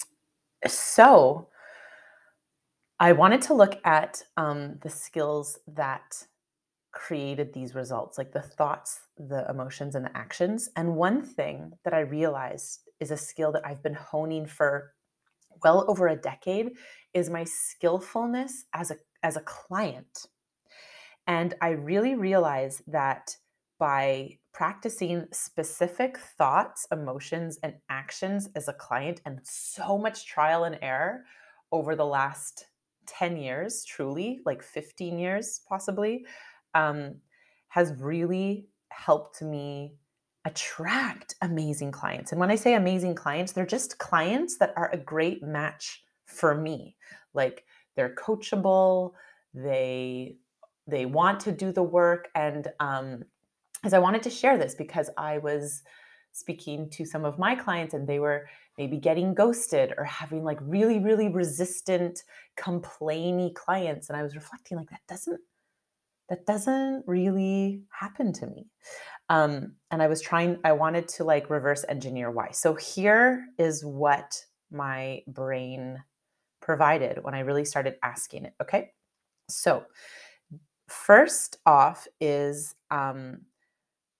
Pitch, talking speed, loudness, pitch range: 165 Hz, 135 wpm, -27 LUFS, 145-190 Hz